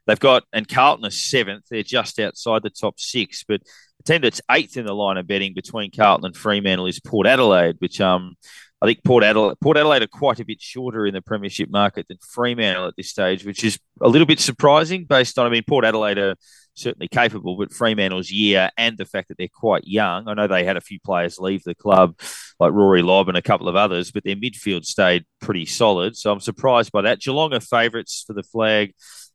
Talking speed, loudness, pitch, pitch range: 225 wpm, -19 LUFS, 105 Hz, 95-115 Hz